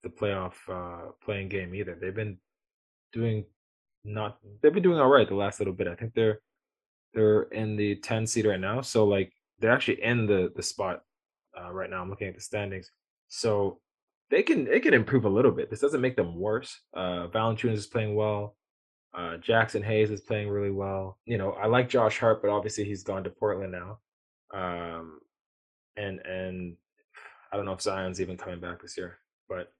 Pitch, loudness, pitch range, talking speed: 105 Hz, -28 LUFS, 95-110 Hz, 195 wpm